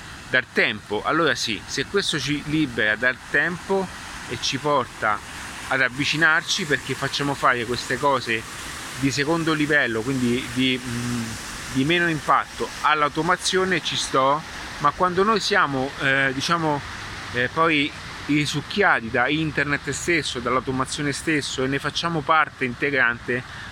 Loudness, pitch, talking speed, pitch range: -22 LUFS, 140 Hz, 125 wpm, 125-155 Hz